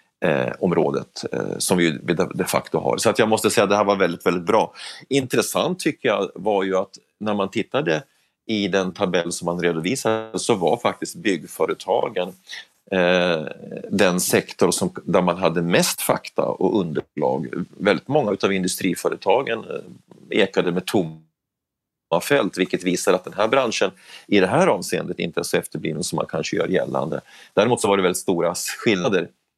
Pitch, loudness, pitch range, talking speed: 95 Hz, -21 LUFS, 85-100 Hz, 170 wpm